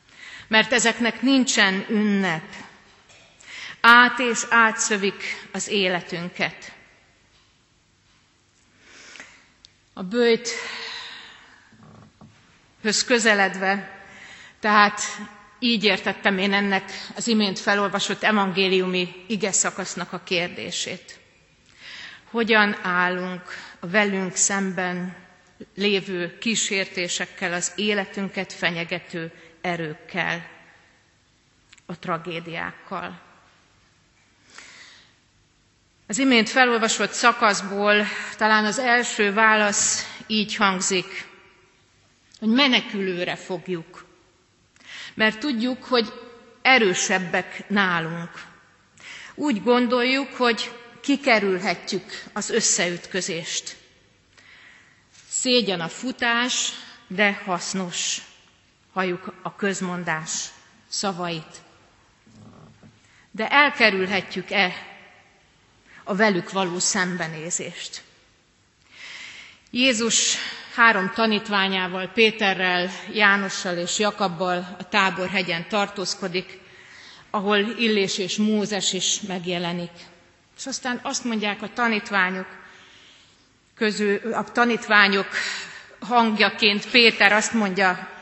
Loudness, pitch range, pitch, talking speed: -21 LUFS, 185-220 Hz, 200 Hz, 70 wpm